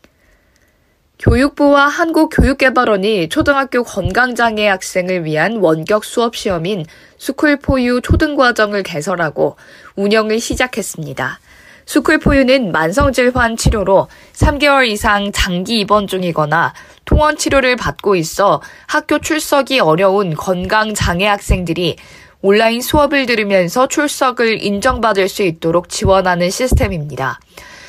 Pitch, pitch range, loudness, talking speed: 215 Hz, 180-265 Hz, -14 LUFS, 290 characters per minute